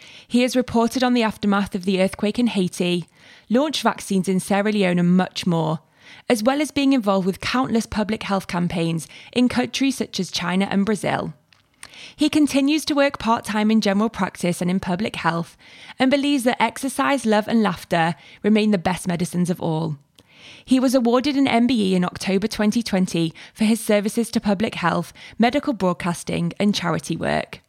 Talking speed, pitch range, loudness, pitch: 175 wpm, 180-240 Hz, -21 LUFS, 205 Hz